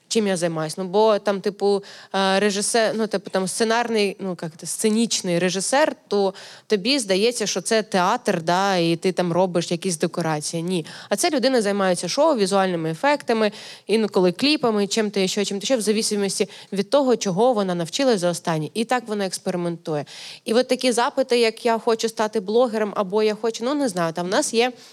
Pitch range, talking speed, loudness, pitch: 185-230 Hz, 180 wpm, -21 LUFS, 205 Hz